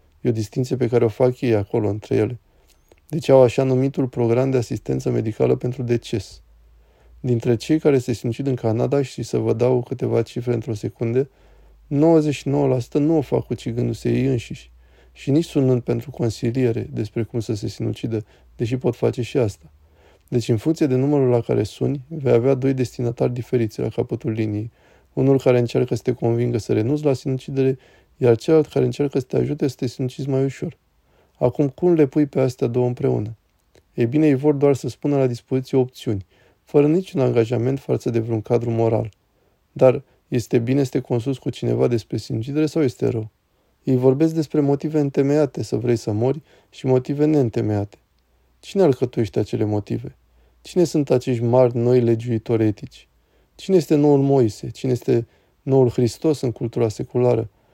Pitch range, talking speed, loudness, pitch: 115-135 Hz, 175 wpm, -21 LUFS, 125 Hz